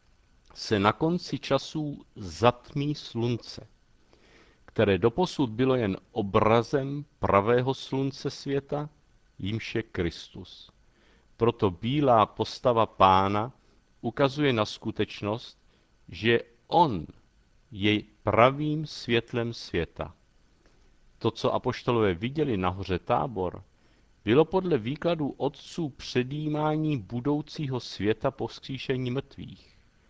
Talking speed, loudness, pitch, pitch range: 90 wpm, -27 LUFS, 120 Hz, 105-145 Hz